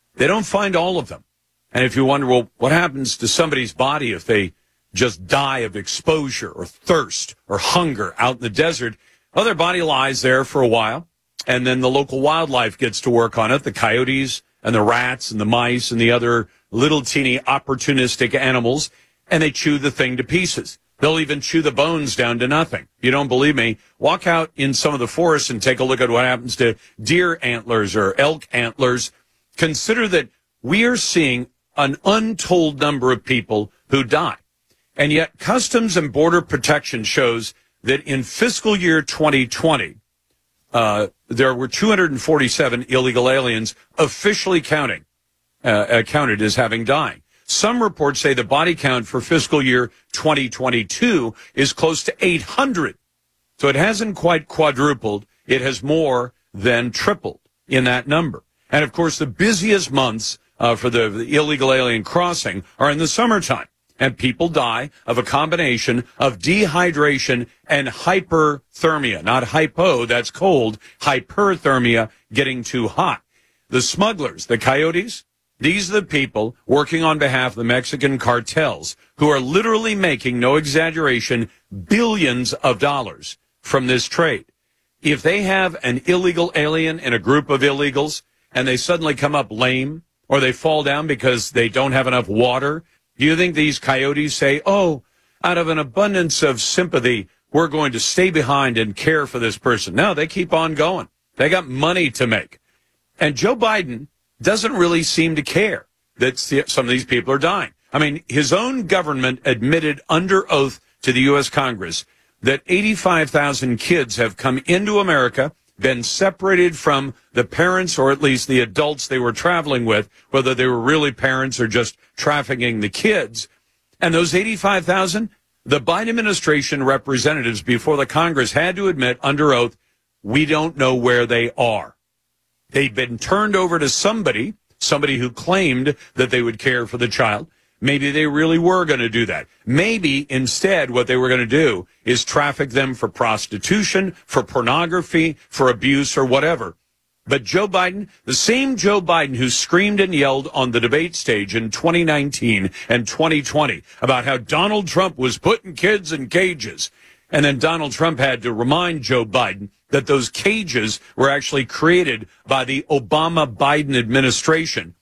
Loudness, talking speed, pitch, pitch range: -18 LUFS, 165 wpm, 140 Hz, 125-160 Hz